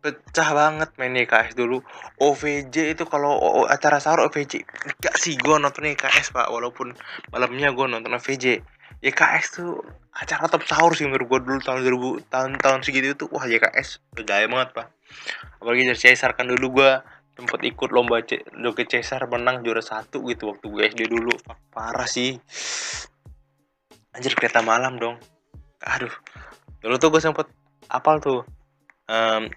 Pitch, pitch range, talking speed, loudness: 130 Hz, 120-145 Hz, 150 wpm, -21 LUFS